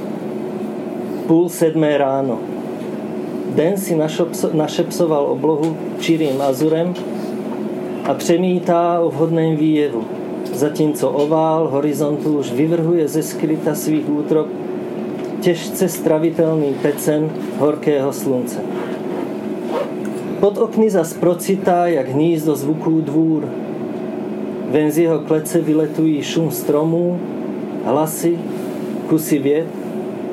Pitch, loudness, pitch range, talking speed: 160 Hz, -18 LUFS, 150-170 Hz, 90 wpm